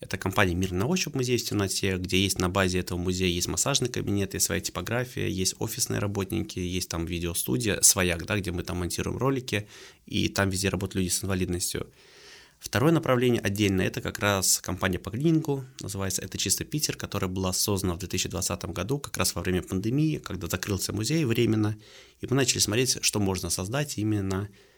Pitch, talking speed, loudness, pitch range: 95 Hz, 185 wpm, -27 LUFS, 90-115 Hz